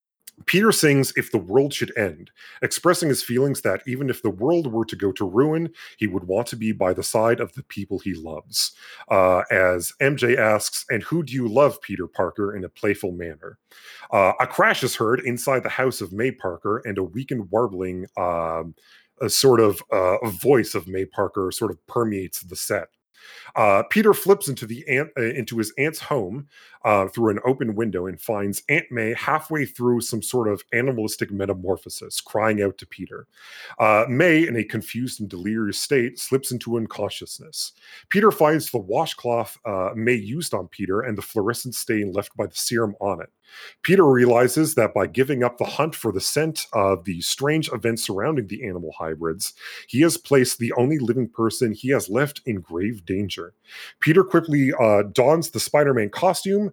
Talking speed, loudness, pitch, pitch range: 190 wpm, -22 LUFS, 120 Hz, 100-140 Hz